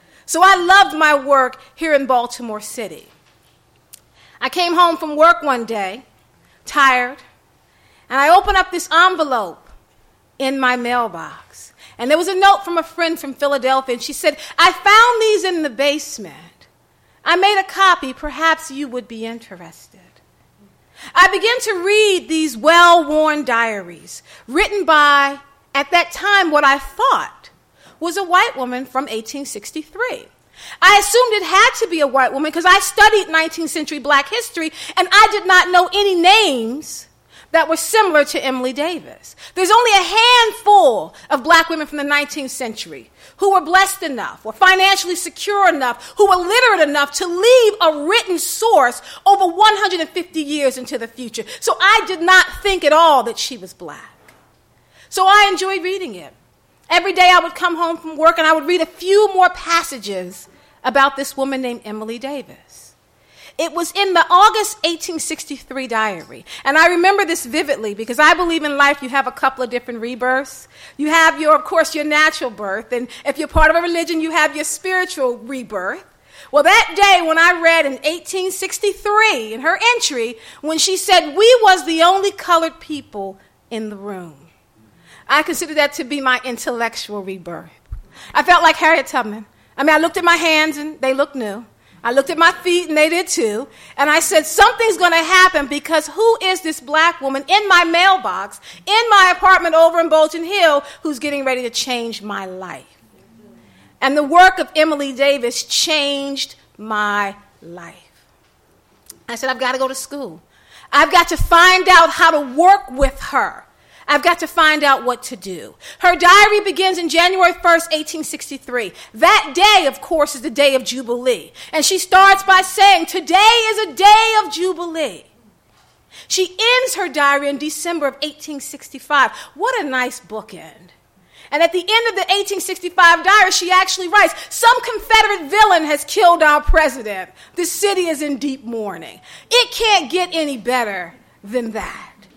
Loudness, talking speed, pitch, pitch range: -14 LUFS, 175 wpm, 320 Hz, 270-370 Hz